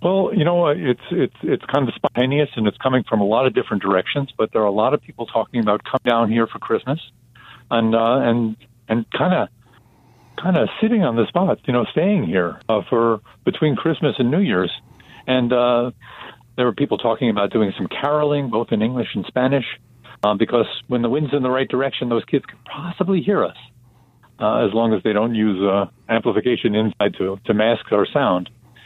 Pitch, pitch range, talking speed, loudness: 120 Hz, 115-135 Hz, 210 wpm, -19 LUFS